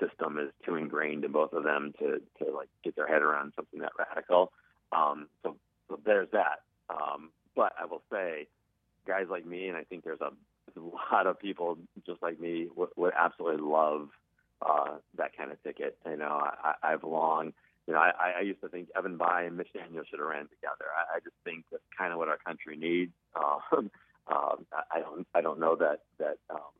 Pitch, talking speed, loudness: 90 Hz, 210 wpm, -32 LUFS